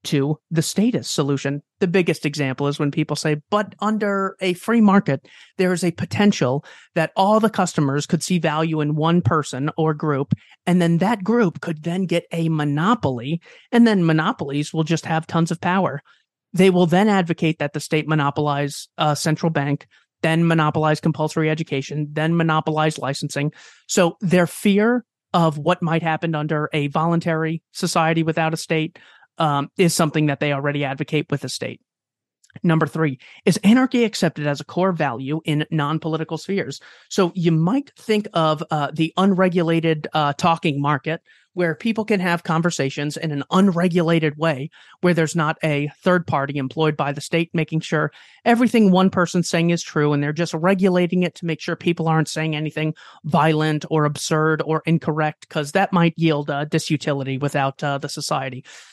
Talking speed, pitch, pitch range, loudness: 175 wpm, 160 Hz, 150-175 Hz, -20 LUFS